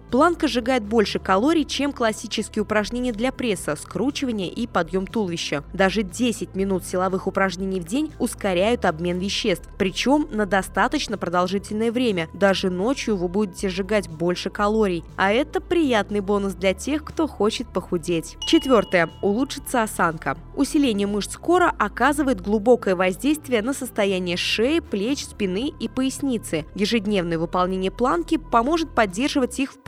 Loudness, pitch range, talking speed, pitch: -22 LUFS, 190-260 Hz, 135 wpm, 210 Hz